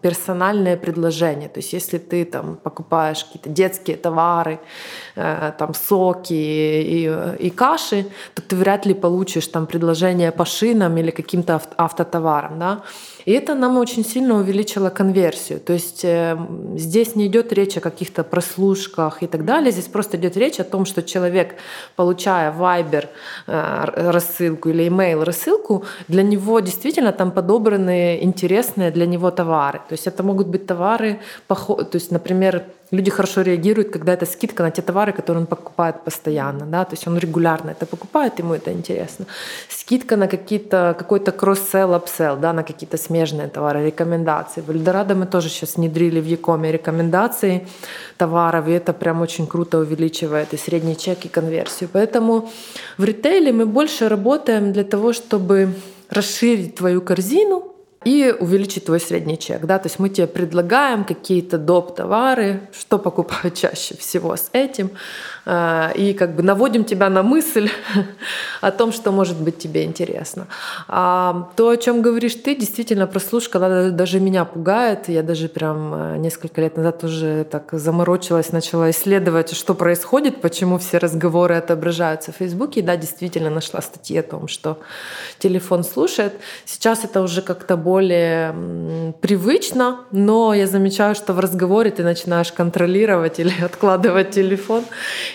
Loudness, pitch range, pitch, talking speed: -19 LUFS, 170-200 Hz, 180 Hz, 155 wpm